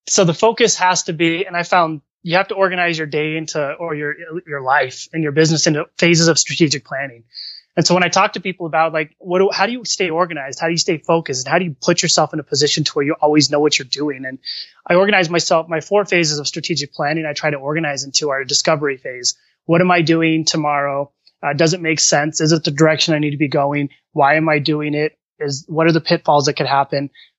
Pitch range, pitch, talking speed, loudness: 145-170 Hz, 160 Hz, 255 wpm, -16 LUFS